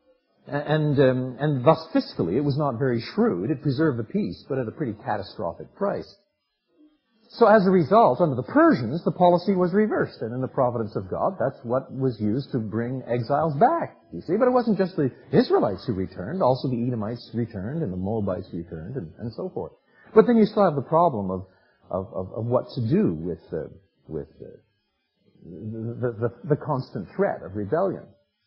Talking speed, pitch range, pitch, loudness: 195 wpm, 115-180 Hz, 135 Hz, -24 LUFS